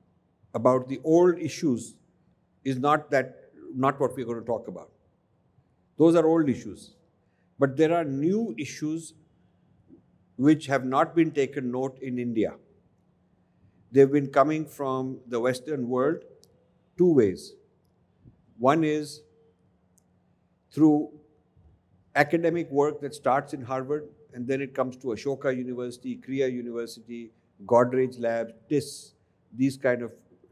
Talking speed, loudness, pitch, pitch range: 130 wpm, -26 LUFS, 135 Hz, 120-150 Hz